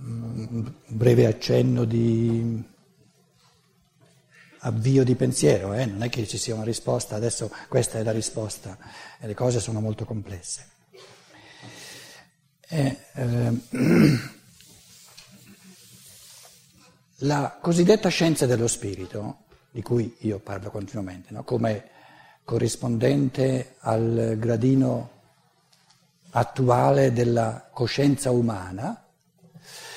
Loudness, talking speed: -24 LUFS, 95 wpm